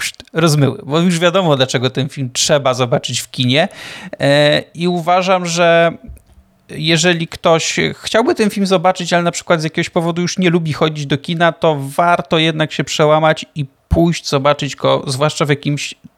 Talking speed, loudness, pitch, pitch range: 165 wpm, -14 LUFS, 160 Hz, 145-175 Hz